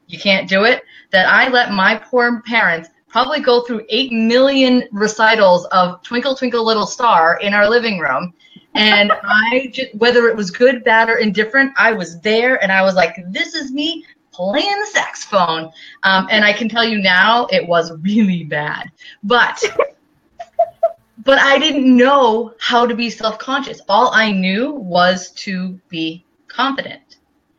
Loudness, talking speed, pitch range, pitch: -14 LUFS, 165 wpm, 195-260 Hz, 230 Hz